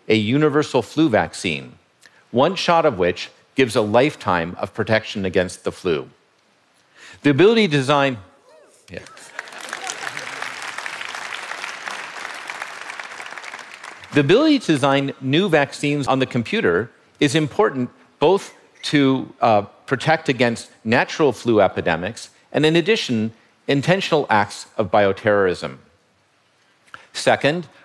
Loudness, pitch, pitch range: -20 LUFS, 140 Hz, 110-150 Hz